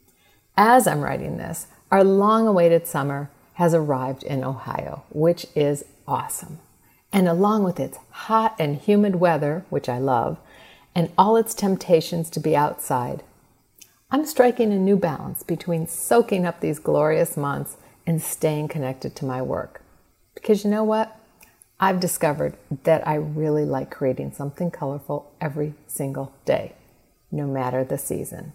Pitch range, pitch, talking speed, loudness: 145-190 Hz, 160 Hz, 145 wpm, -22 LUFS